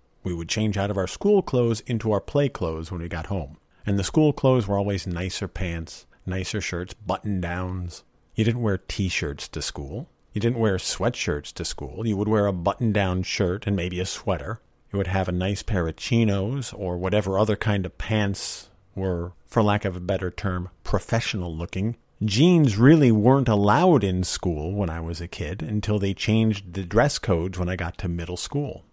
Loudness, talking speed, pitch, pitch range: -24 LUFS, 205 wpm, 100 Hz, 90-110 Hz